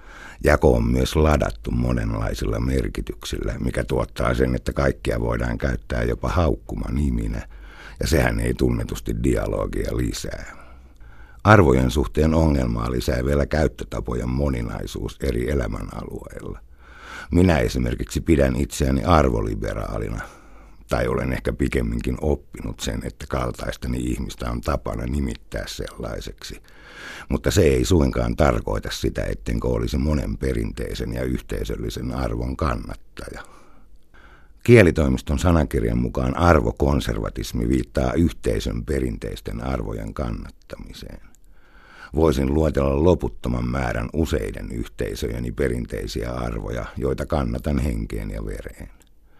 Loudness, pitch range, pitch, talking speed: -23 LUFS, 60-75 Hz, 65 Hz, 105 wpm